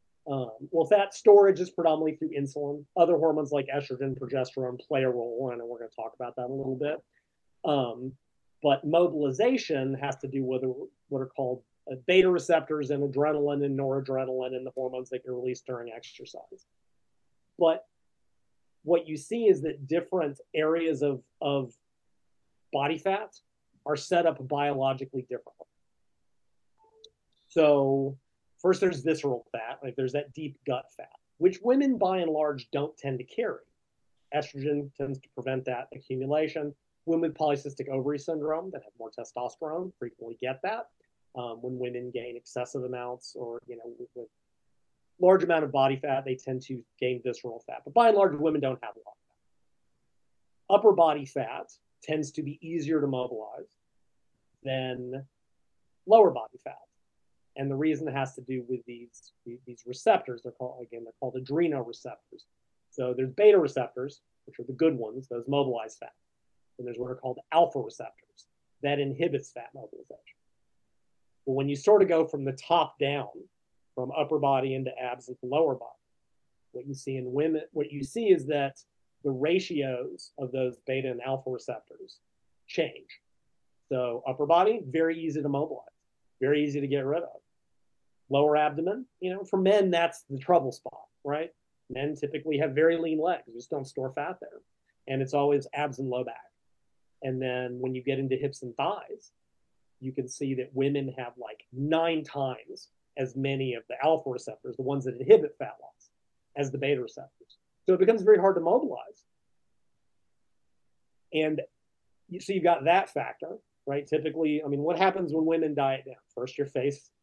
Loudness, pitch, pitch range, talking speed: -28 LUFS, 140 Hz, 130-160 Hz, 170 wpm